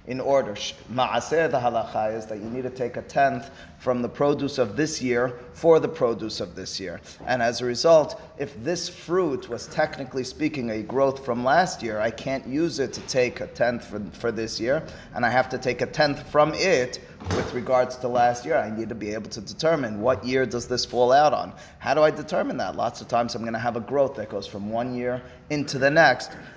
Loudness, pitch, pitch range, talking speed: -24 LUFS, 125 Hz, 120-140 Hz, 230 wpm